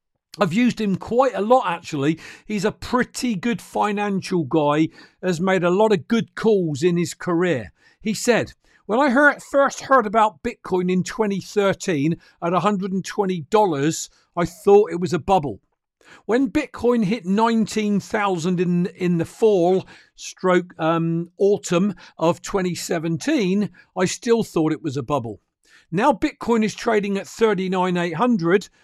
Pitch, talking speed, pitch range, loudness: 195 Hz, 140 wpm, 175-220 Hz, -21 LUFS